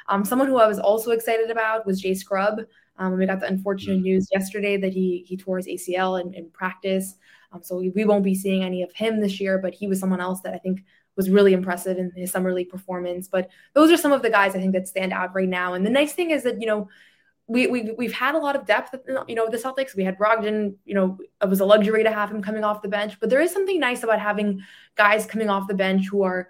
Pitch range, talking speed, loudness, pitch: 185-220 Hz, 270 wpm, -22 LUFS, 200 Hz